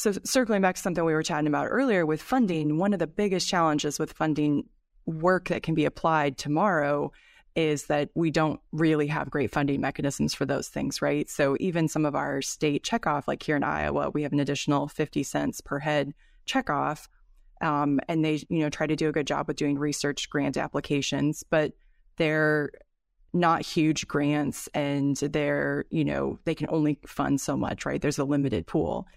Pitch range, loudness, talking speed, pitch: 145-165 Hz, -27 LUFS, 195 wpm, 150 Hz